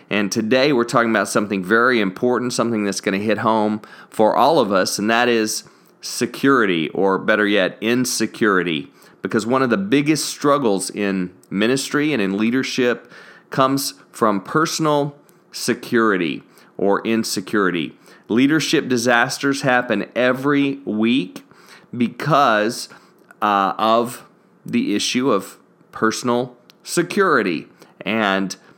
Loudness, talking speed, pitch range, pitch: -19 LUFS, 120 wpm, 105-135 Hz, 120 Hz